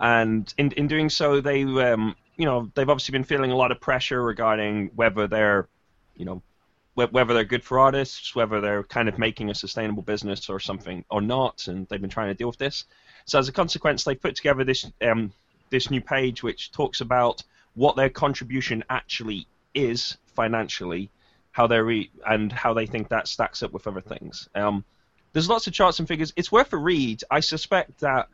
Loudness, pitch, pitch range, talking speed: -24 LUFS, 120 Hz, 105-135 Hz, 205 wpm